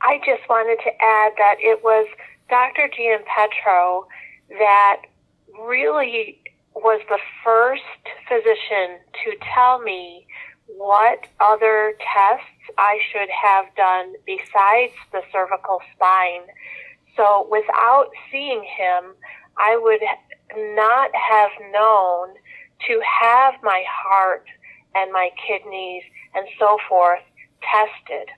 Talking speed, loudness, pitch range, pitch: 110 wpm, -18 LUFS, 195-250 Hz, 215 Hz